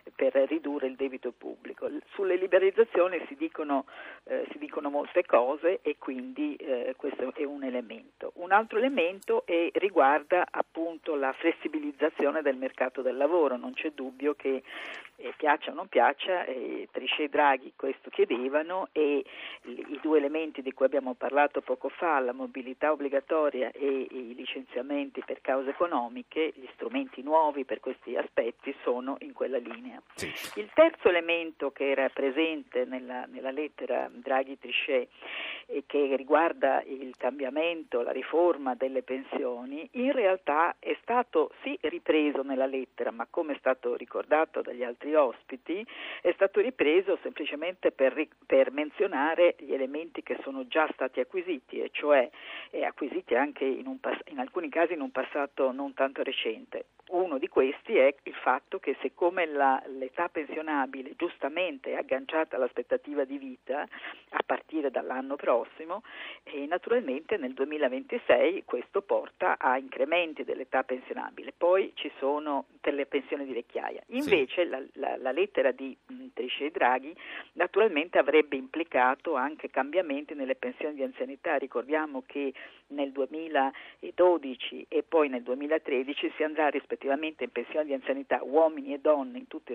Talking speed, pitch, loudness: 145 wpm, 160 Hz, -30 LUFS